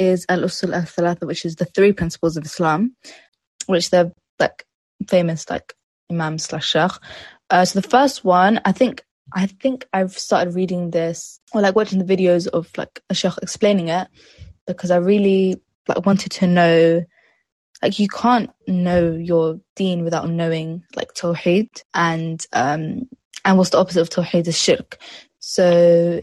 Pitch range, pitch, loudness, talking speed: 170-195 Hz, 180 Hz, -19 LUFS, 160 wpm